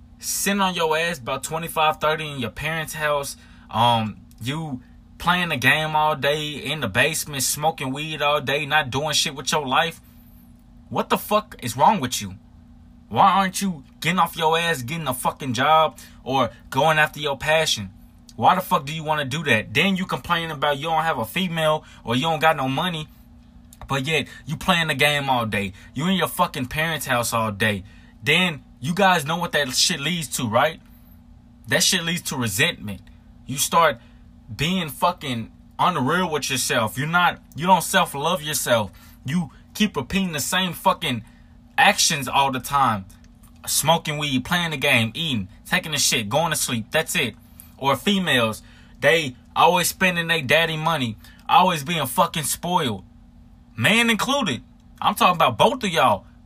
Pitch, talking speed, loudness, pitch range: 150 Hz, 175 wpm, -21 LUFS, 120-165 Hz